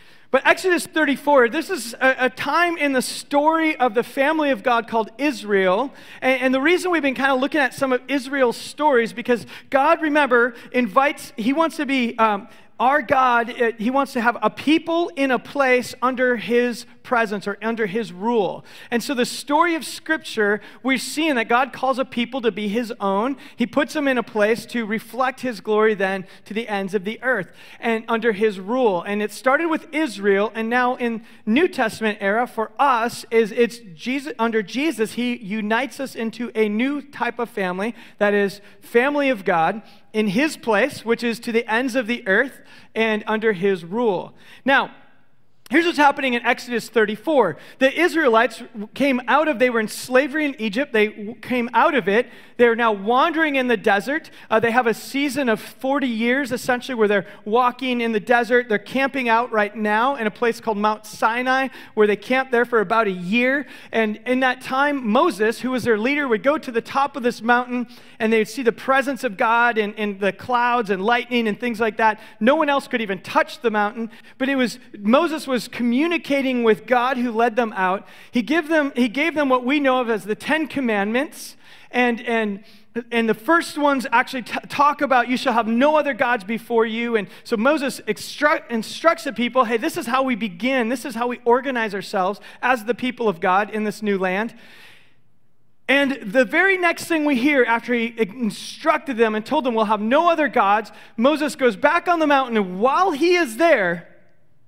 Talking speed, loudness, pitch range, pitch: 200 wpm, -20 LUFS, 220-275 Hz, 240 Hz